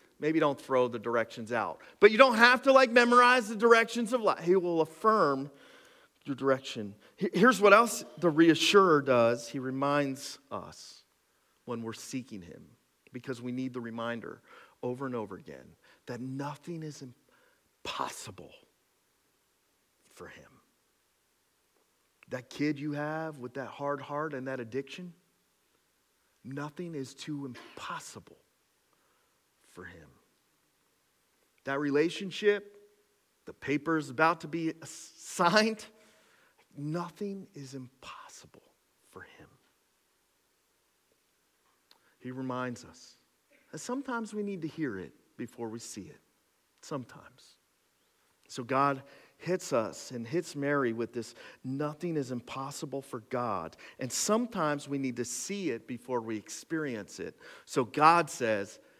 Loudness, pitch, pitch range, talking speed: -29 LUFS, 145 Hz, 130-195 Hz, 125 wpm